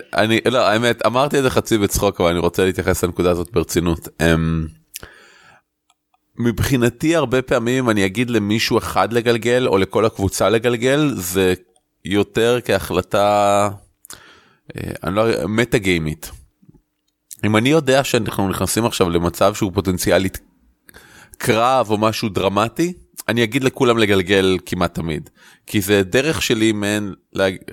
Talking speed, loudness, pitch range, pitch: 130 wpm, -18 LUFS, 95-120 Hz, 105 Hz